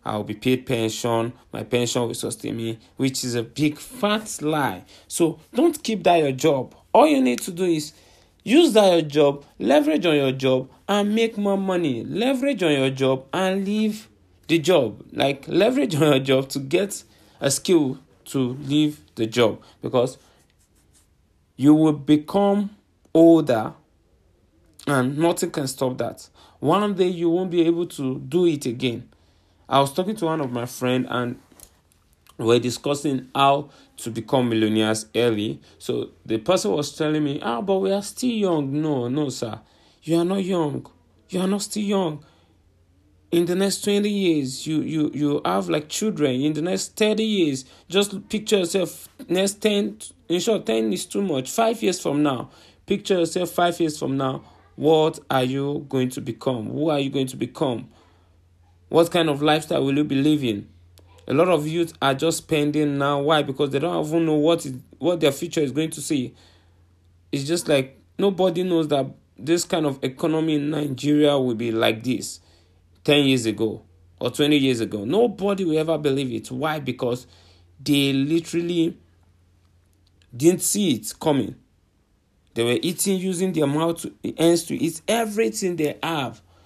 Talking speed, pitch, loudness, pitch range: 170 wpm, 145 Hz, -22 LUFS, 120-170 Hz